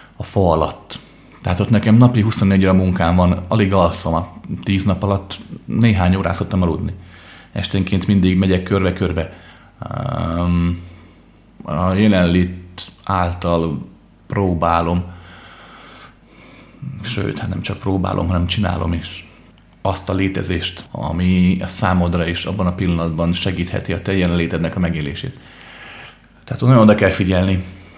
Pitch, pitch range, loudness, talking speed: 90 Hz, 85-100 Hz, -18 LUFS, 120 wpm